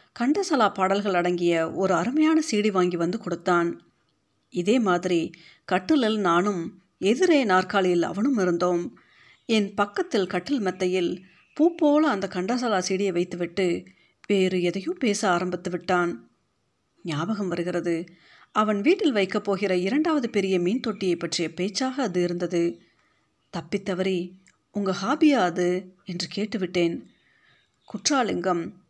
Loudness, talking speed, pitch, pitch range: -24 LUFS, 110 wpm, 185 Hz, 175-215 Hz